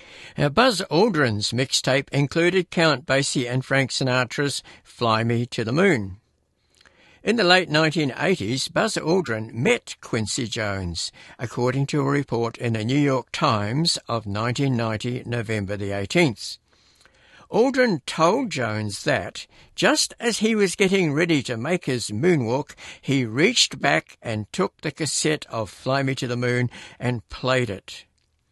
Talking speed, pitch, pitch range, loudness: 145 wpm, 130 Hz, 115-160 Hz, -22 LUFS